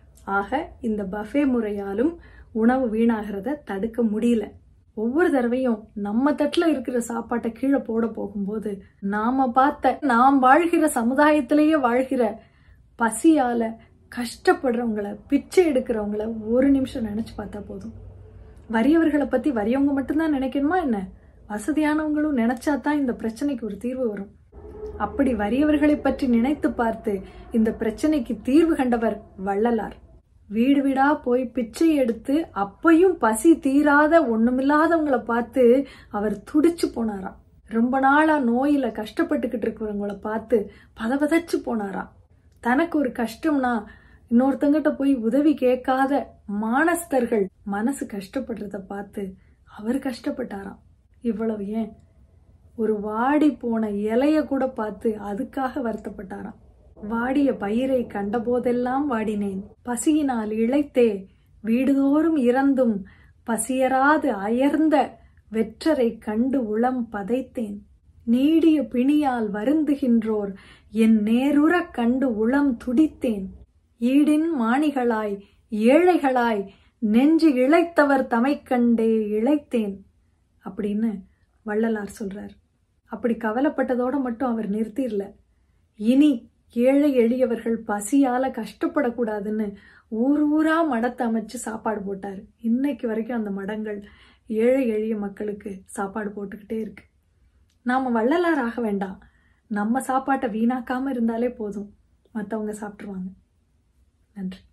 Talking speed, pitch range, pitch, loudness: 95 wpm, 215-275 Hz, 240 Hz, -22 LUFS